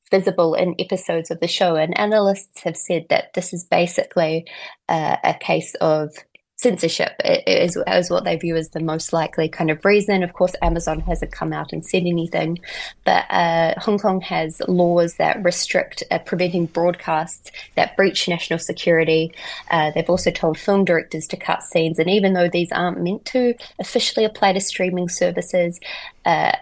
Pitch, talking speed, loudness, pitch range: 175 Hz, 175 wpm, -20 LUFS, 165-190 Hz